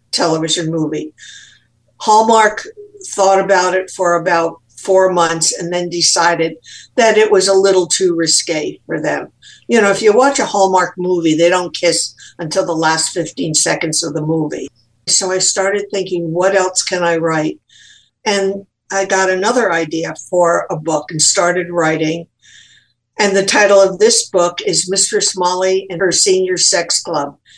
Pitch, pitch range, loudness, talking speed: 180 Hz, 165-195 Hz, -14 LUFS, 165 wpm